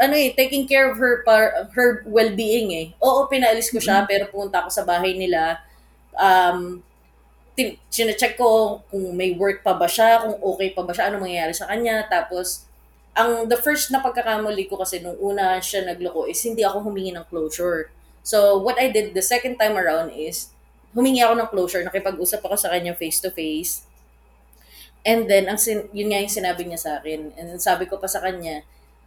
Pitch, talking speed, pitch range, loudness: 195 Hz, 190 wpm, 170-225 Hz, -20 LUFS